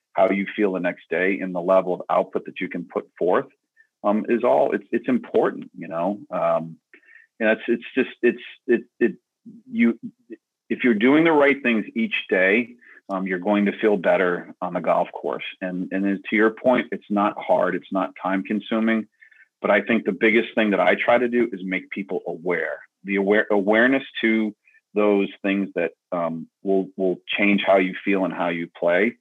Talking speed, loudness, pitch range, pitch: 200 wpm, -22 LUFS, 95-120 Hz, 105 Hz